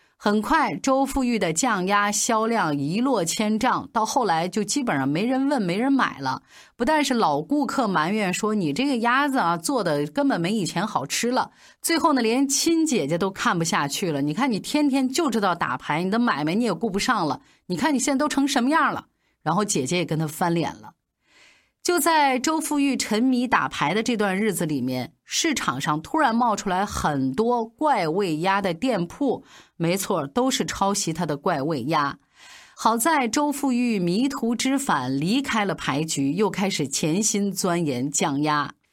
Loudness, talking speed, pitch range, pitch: -23 LUFS, 265 characters per minute, 175-265 Hz, 215 Hz